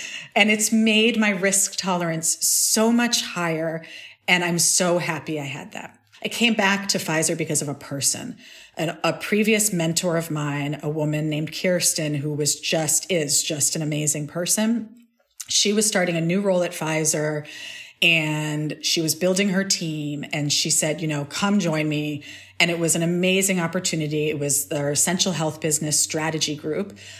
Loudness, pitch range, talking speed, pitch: -21 LUFS, 150-190 Hz, 170 wpm, 165 Hz